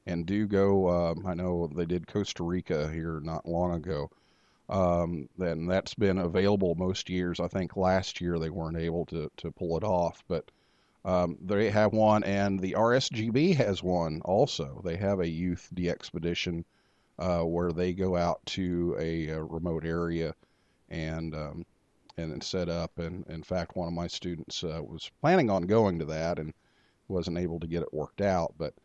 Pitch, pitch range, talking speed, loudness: 85 Hz, 85-95 Hz, 185 wpm, -30 LUFS